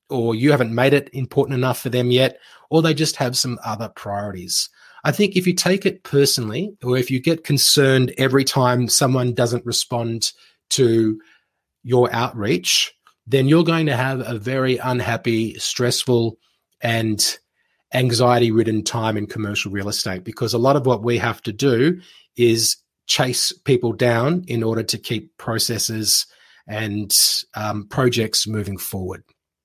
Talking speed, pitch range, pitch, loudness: 155 wpm, 110-135 Hz, 120 Hz, -19 LUFS